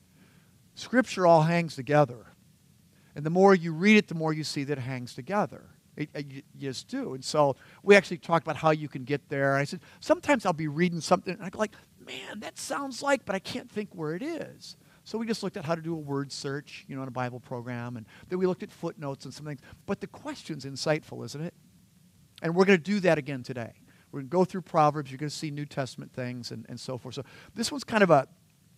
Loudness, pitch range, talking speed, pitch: -28 LUFS, 140-185 Hz, 250 wpm, 155 Hz